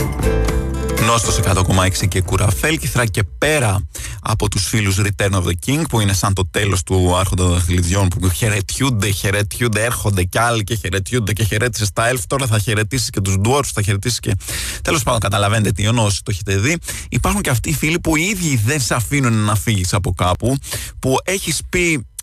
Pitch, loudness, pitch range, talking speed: 105 Hz, -17 LUFS, 95-125 Hz, 190 wpm